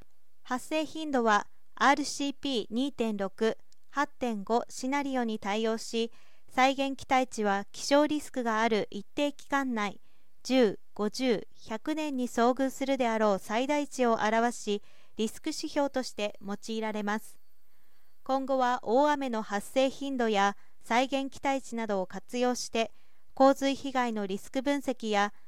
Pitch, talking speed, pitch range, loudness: 245 Hz, 240 characters per minute, 220-275 Hz, -30 LUFS